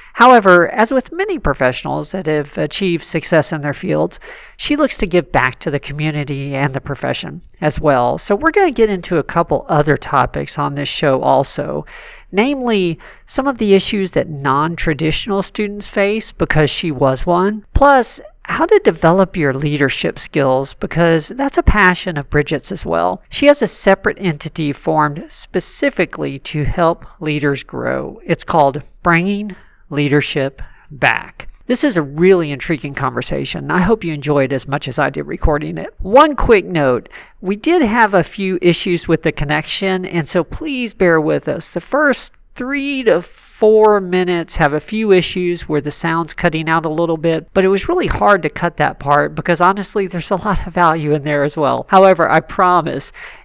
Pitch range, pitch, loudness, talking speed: 150-205 Hz, 175 Hz, -15 LUFS, 180 wpm